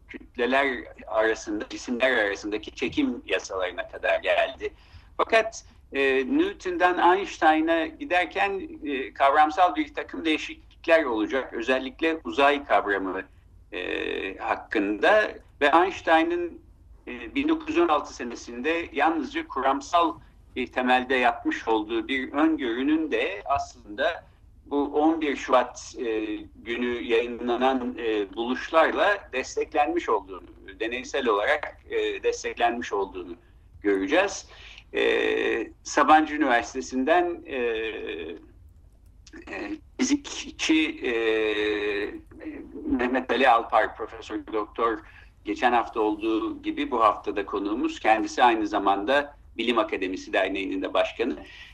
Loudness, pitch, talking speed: -25 LUFS, 285 Hz, 95 wpm